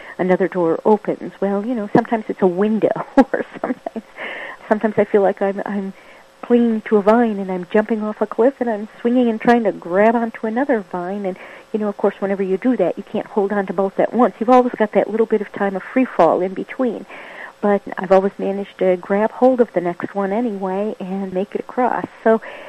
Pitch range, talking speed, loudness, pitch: 195-235 Hz, 225 wpm, -18 LUFS, 210 Hz